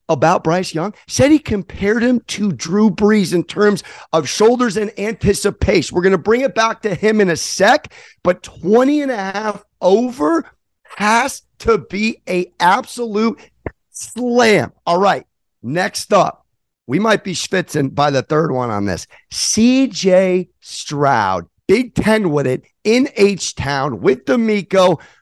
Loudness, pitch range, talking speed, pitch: -16 LUFS, 180-225 Hz, 150 wpm, 205 Hz